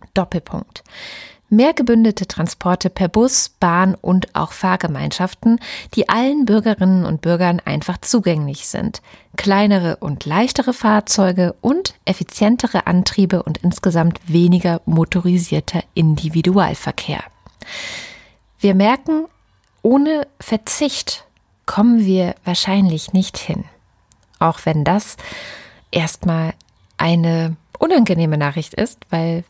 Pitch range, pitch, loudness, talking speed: 165-215 Hz, 180 Hz, -17 LUFS, 100 wpm